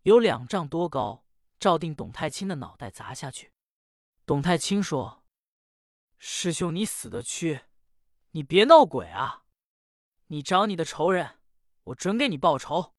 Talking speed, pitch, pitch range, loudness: 200 characters per minute, 165 Hz, 125-195 Hz, -25 LUFS